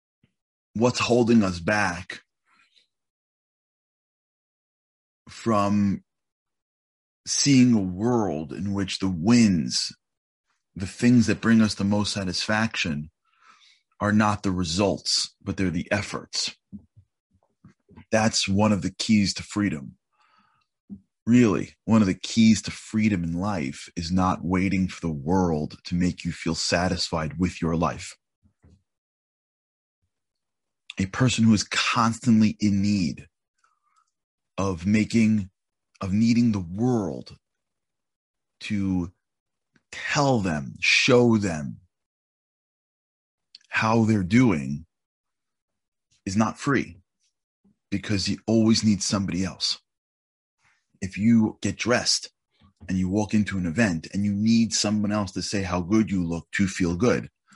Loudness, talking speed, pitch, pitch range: -23 LUFS, 115 wpm, 100 Hz, 90-110 Hz